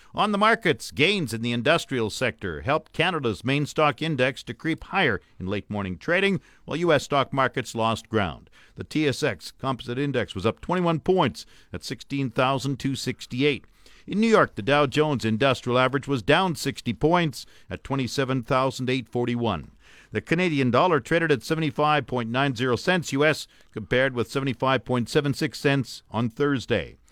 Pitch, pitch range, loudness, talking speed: 135 Hz, 120-150 Hz, -24 LUFS, 140 wpm